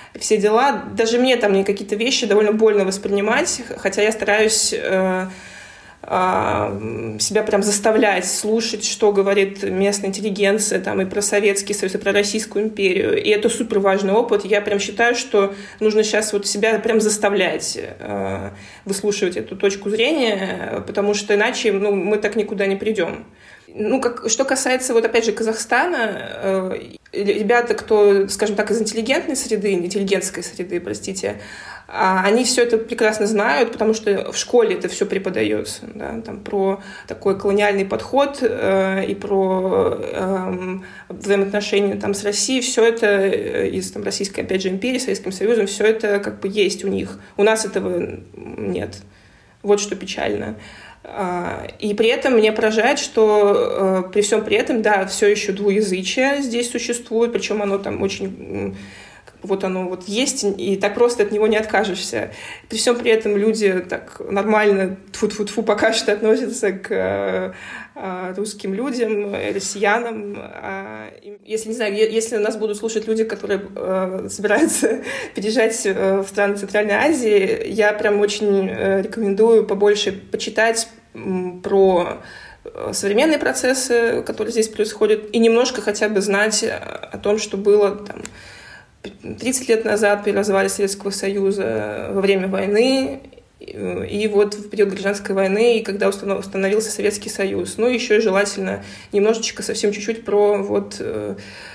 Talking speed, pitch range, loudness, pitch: 145 wpm, 195-220 Hz, -19 LUFS, 205 Hz